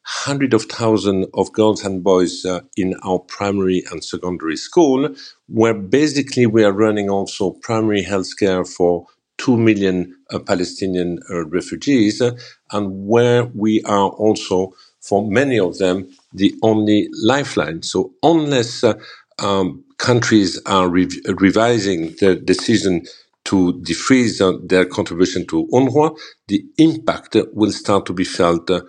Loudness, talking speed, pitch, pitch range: -17 LUFS, 145 wpm, 100 Hz, 90-110 Hz